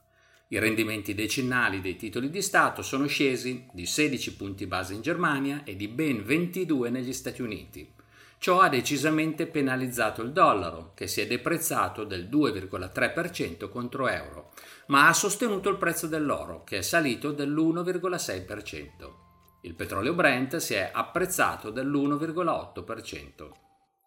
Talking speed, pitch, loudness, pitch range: 130 wpm, 135 Hz, -27 LUFS, 105-160 Hz